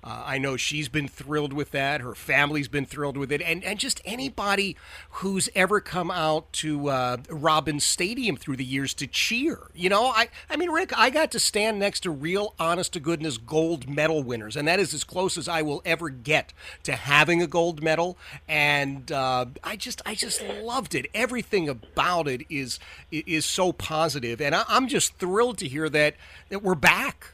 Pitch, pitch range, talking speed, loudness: 160 Hz, 145-185 Hz, 195 wpm, -25 LUFS